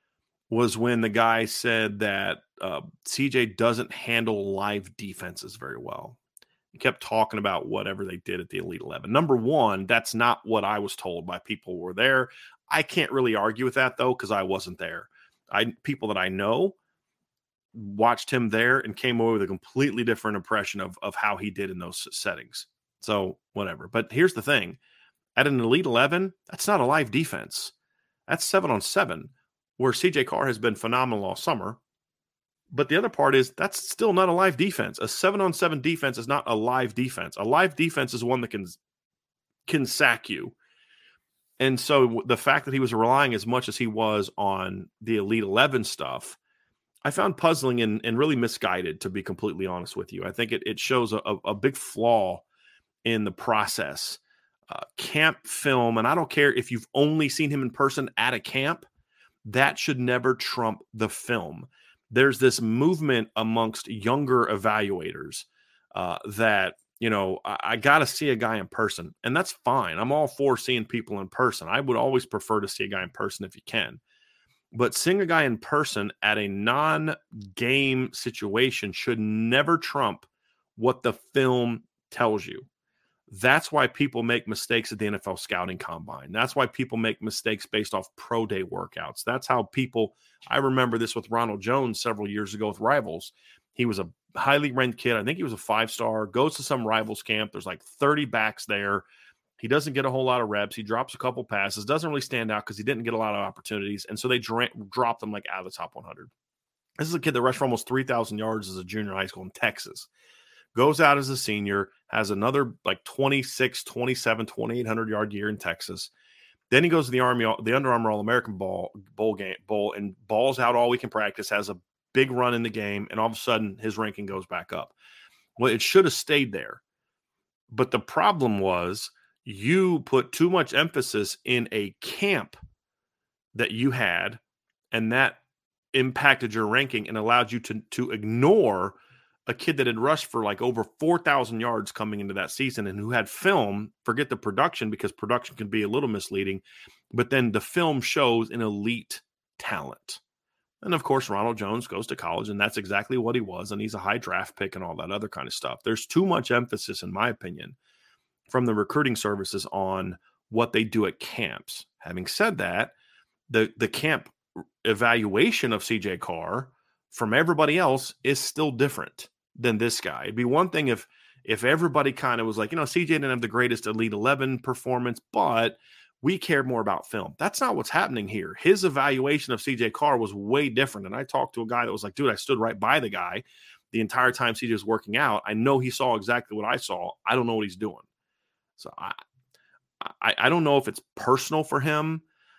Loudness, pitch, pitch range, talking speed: -25 LUFS, 115 Hz, 105-135 Hz, 200 wpm